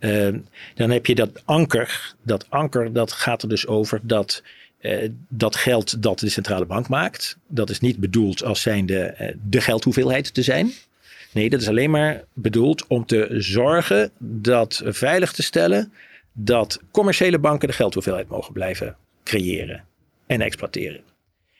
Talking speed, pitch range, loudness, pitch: 160 wpm, 105-130 Hz, -21 LUFS, 115 Hz